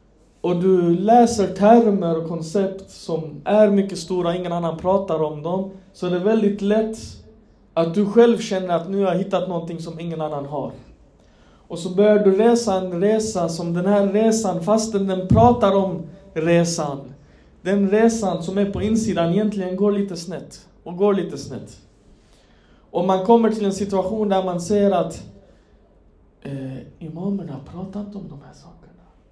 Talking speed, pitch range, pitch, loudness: 165 wpm, 170-205 Hz, 185 Hz, -20 LUFS